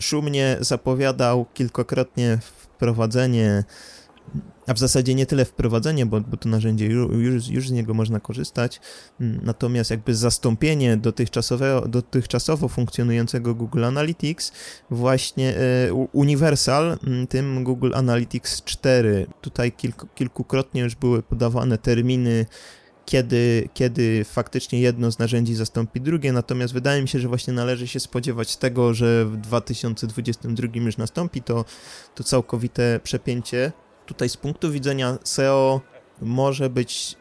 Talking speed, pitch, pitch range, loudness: 120 wpm, 125 Hz, 115-130 Hz, -22 LUFS